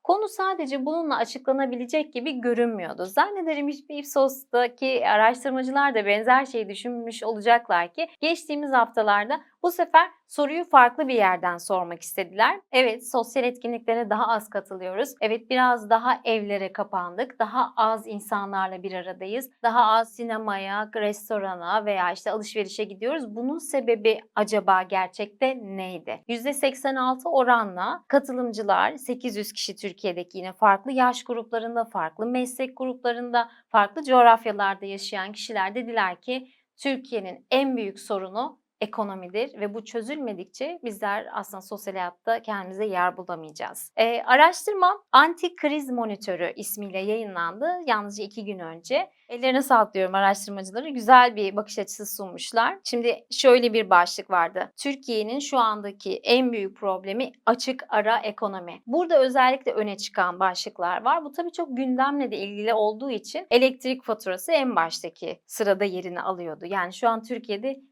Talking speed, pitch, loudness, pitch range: 130 wpm, 230 Hz, -24 LUFS, 200-260 Hz